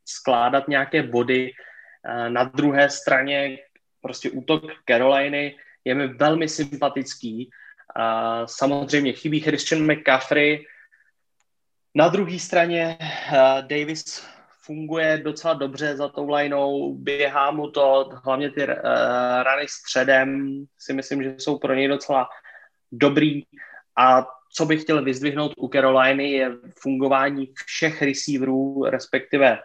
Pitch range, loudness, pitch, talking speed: 130-150 Hz, -21 LUFS, 140 Hz, 110 wpm